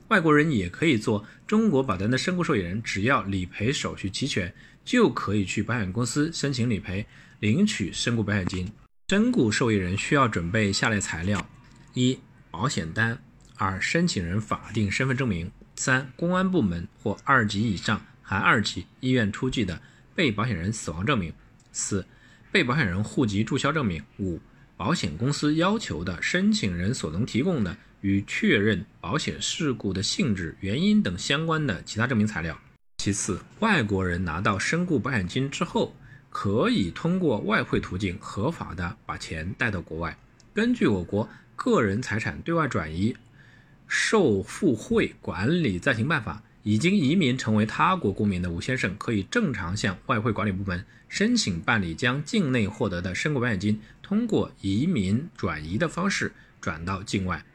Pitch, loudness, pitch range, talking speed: 110 Hz, -26 LUFS, 100-130 Hz, 260 characters per minute